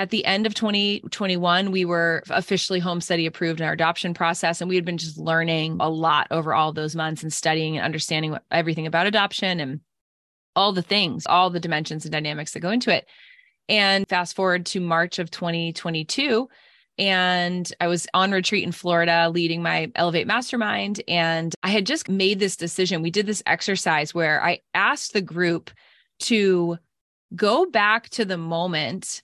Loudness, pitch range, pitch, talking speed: -22 LUFS, 165-195 Hz, 175 Hz, 180 wpm